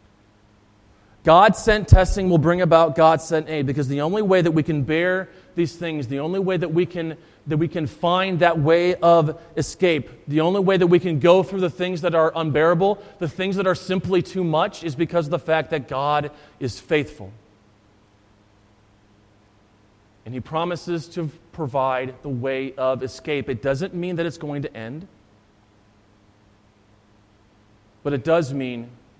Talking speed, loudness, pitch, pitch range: 170 wpm, -21 LUFS, 155 Hz, 110-175 Hz